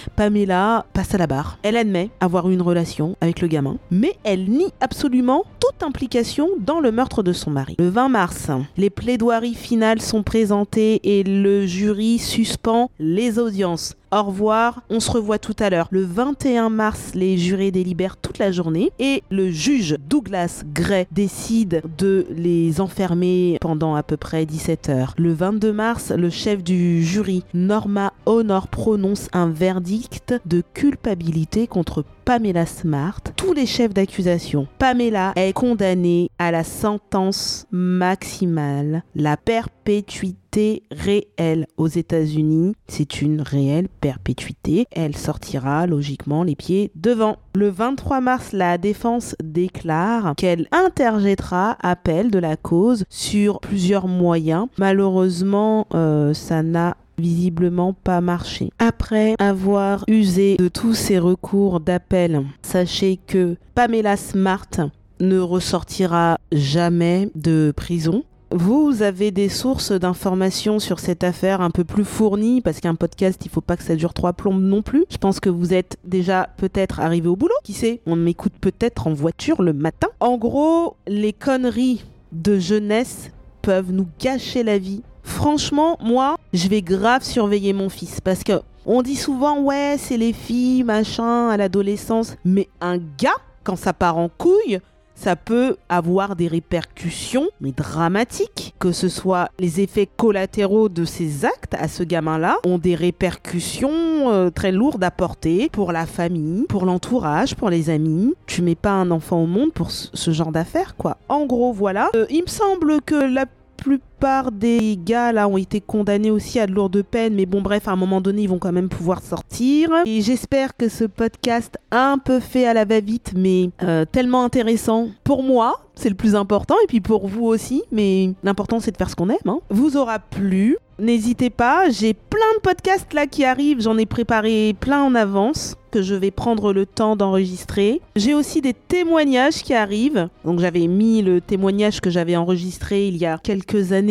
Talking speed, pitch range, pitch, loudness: 165 wpm, 175-230 Hz, 195 Hz, -19 LUFS